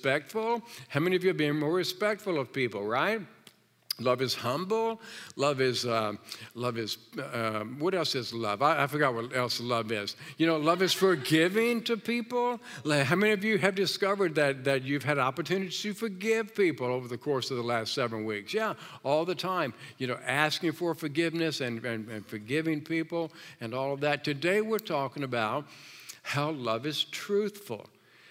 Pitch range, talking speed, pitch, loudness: 125-185 Hz, 185 wpm, 150 Hz, -30 LUFS